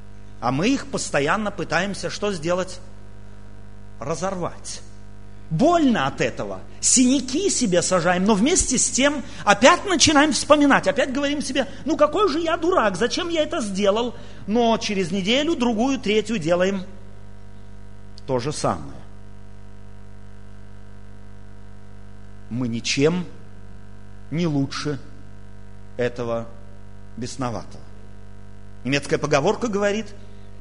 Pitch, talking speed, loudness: 140 Hz, 100 wpm, -21 LUFS